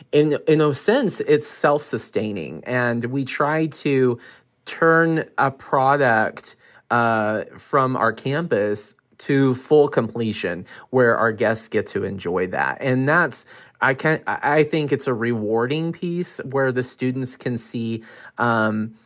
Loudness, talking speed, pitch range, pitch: -21 LUFS, 140 wpm, 120-150 Hz, 130 Hz